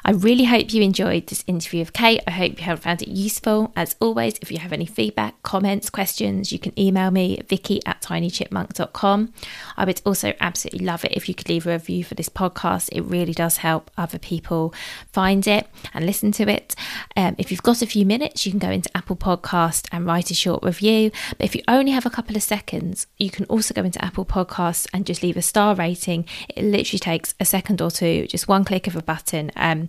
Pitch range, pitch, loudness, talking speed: 170-205 Hz, 185 Hz, -21 LUFS, 225 wpm